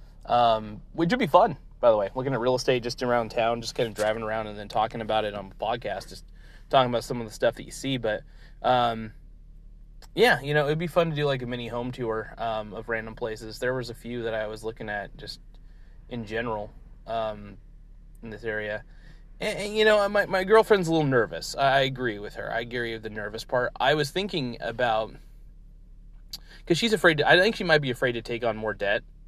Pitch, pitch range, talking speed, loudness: 120 Hz, 110-140 Hz, 230 wpm, -26 LUFS